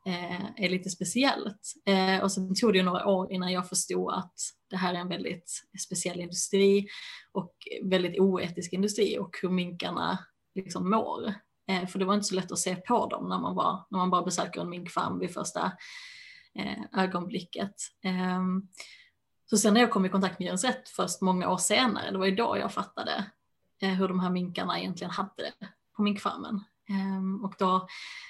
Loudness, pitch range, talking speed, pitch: -29 LUFS, 185-205 Hz, 170 wpm, 190 Hz